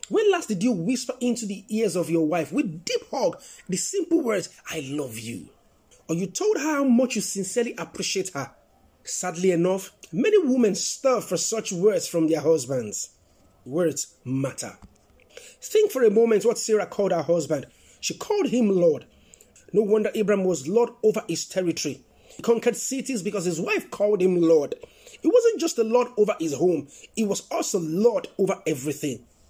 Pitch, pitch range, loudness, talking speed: 205 Hz, 165-245 Hz, -24 LUFS, 175 wpm